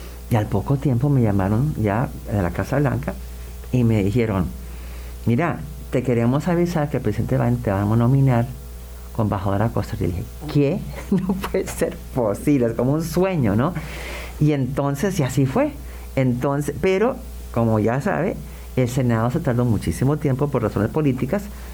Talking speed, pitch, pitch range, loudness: 165 wpm, 120 Hz, 100-140 Hz, -21 LUFS